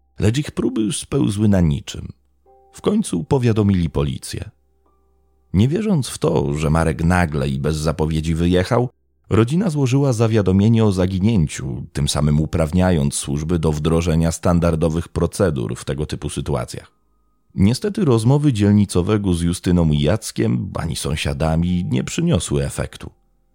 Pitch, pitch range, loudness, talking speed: 85 Hz, 75-110 Hz, -19 LUFS, 125 wpm